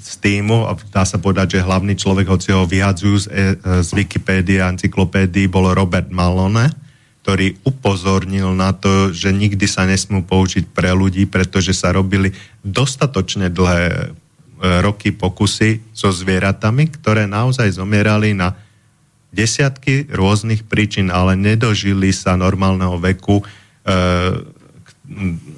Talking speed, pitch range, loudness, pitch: 130 wpm, 95-105 Hz, -16 LUFS, 95 Hz